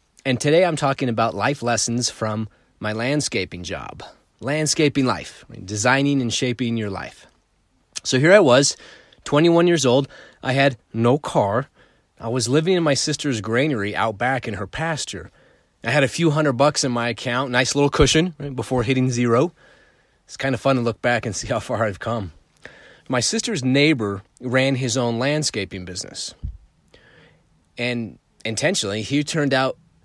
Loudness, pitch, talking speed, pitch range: -20 LUFS, 125 Hz, 165 wpm, 115-145 Hz